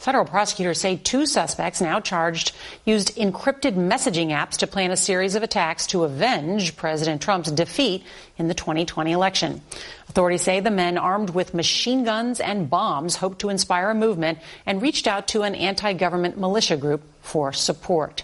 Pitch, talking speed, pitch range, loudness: 185 Hz, 170 wpm, 170-205 Hz, -22 LUFS